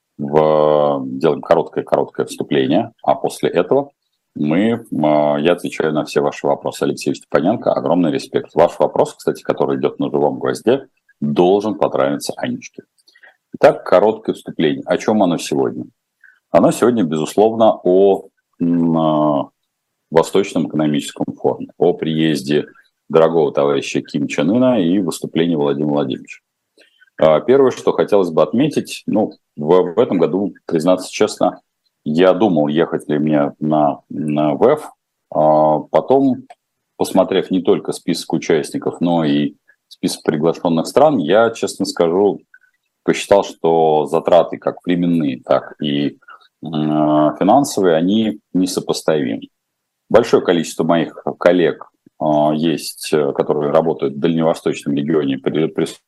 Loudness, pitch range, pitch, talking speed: -16 LUFS, 75-85 Hz, 75 Hz, 115 wpm